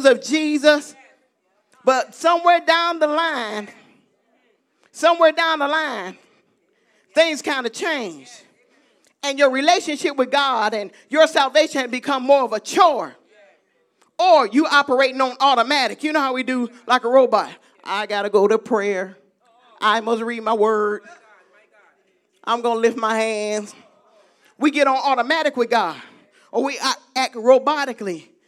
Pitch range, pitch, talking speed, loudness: 225-300 Hz, 260 Hz, 140 wpm, -19 LUFS